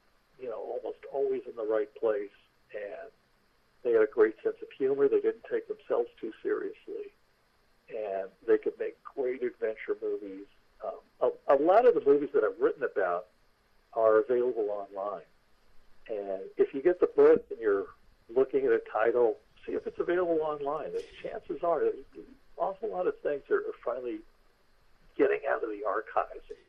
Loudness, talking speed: -30 LUFS, 170 wpm